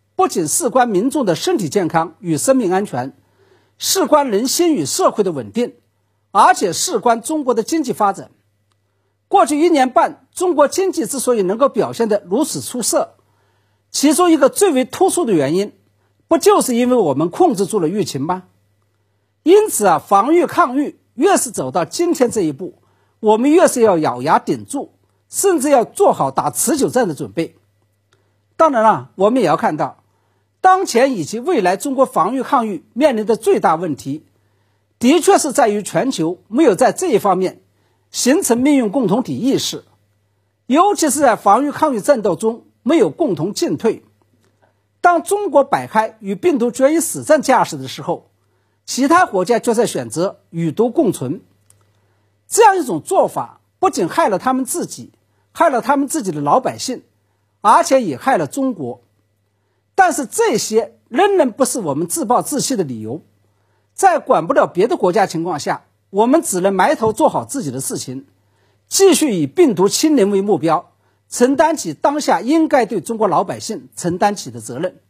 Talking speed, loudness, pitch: 255 characters per minute, -16 LUFS, 230 Hz